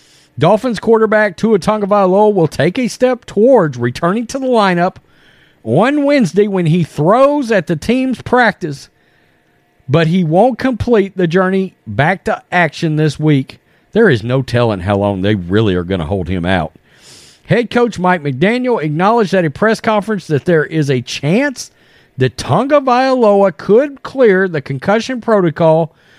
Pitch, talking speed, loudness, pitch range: 180 Hz, 155 wpm, -13 LUFS, 140-220 Hz